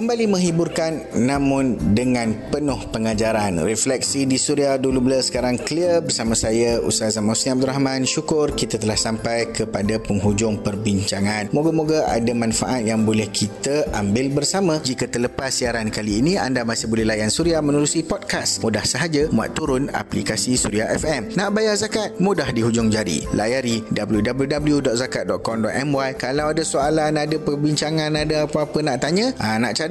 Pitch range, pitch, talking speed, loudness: 110-150 Hz, 130 Hz, 145 wpm, -20 LUFS